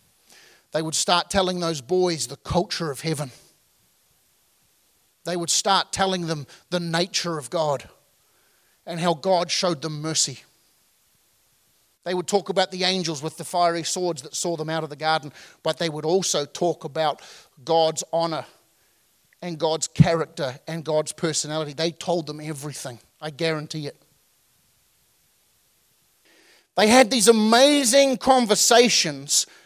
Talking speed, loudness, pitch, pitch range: 140 wpm, -22 LUFS, 165 Hz, 155-180 Hz